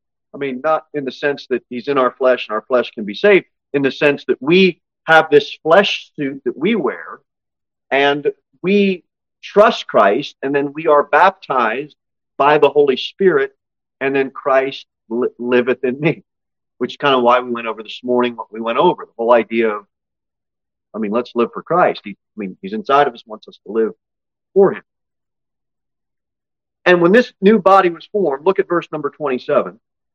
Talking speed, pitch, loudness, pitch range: 195 wpm, 140 Hz, -16 LUFS, 120-175 Hz